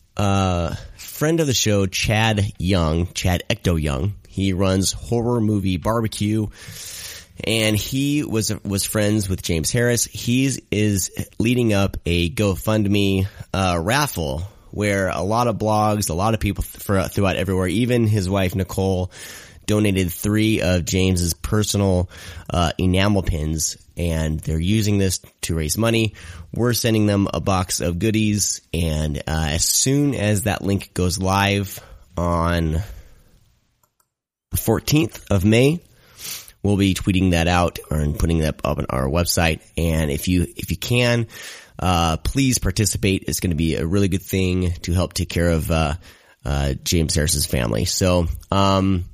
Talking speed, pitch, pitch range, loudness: 155 wpm, 95 Hz, 85-105 Hz, -20 LUFS